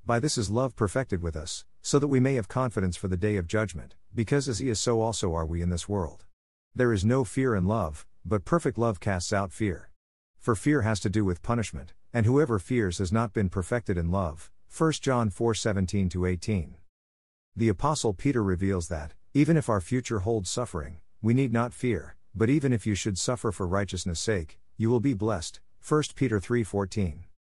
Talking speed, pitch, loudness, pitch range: 205 wpm, 105 Hz, -28 LUFS, 90-120 Hz